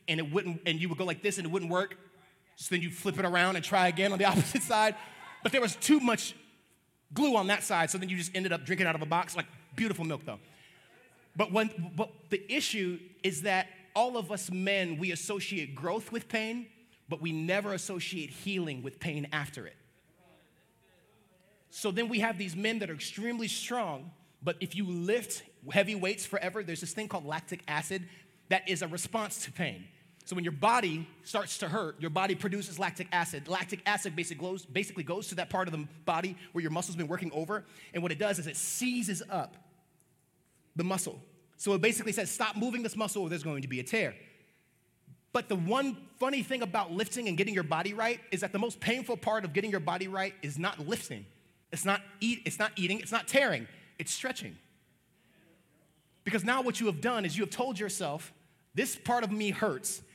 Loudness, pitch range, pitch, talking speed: -32 LUFS, 170-215 Hz, 190 Hz, 210 wpm